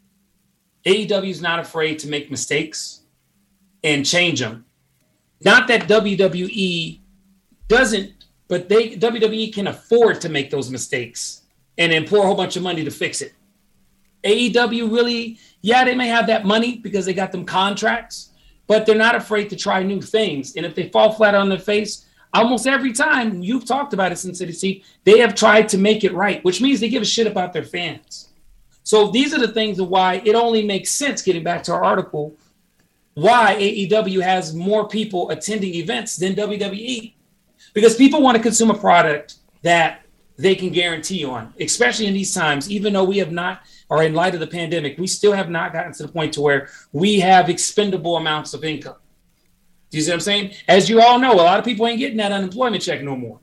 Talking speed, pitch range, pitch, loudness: 200 wpm, 170-220 Hz, 195 Hz, -18 LUFS